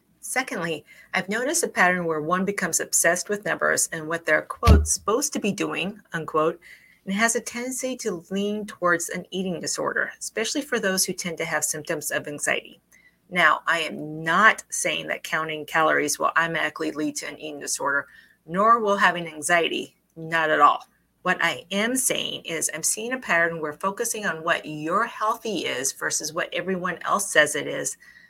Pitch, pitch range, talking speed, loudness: 180 Hz, 160-210 Hz, 180 wpm, -23 LUFS